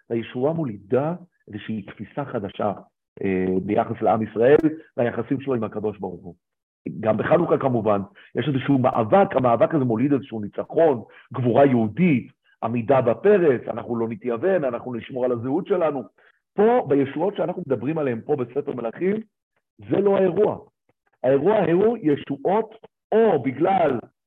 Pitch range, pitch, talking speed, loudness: 115-160 Hz, 130 Hz, 135 wpm, -22 LUFS